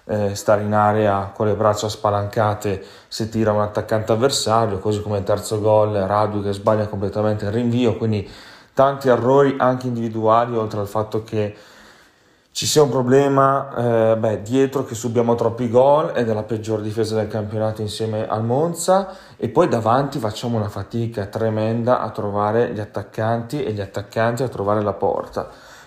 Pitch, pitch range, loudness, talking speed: 110 Hz, 105-120 Hz, -20 LUFS, 165 wpm